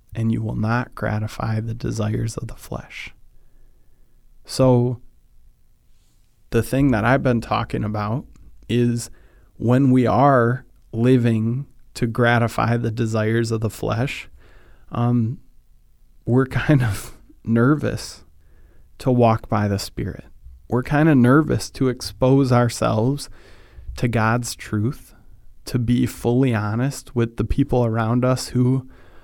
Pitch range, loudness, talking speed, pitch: 110-125 Hz, -20 LUFS, 125 wpm, 120 Hz